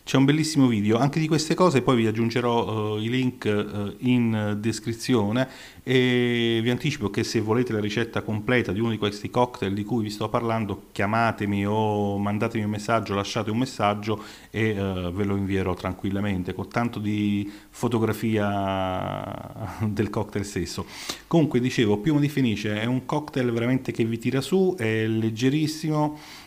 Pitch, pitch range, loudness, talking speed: 110 Hz, 105-125 Hz, -25 LUFS, 165 wpm